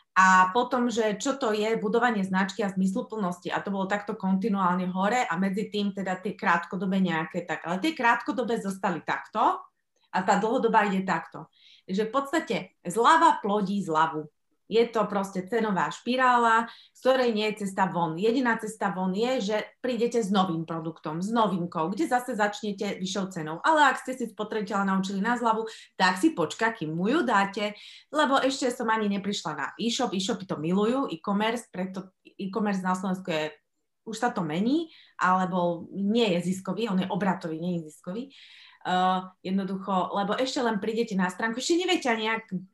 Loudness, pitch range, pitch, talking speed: -27 LUFS, 185-230 Hz, 205 Hz, 175 wpm